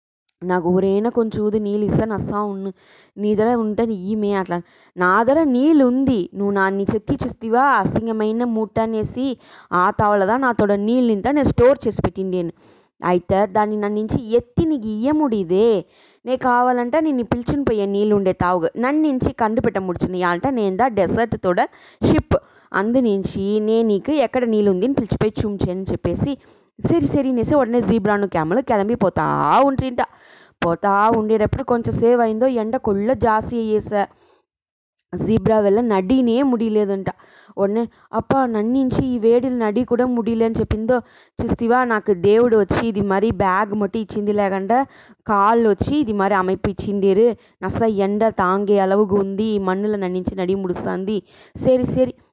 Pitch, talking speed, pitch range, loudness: 215 Hz, 140 wpm, 200-240 Hz, -19 LUFS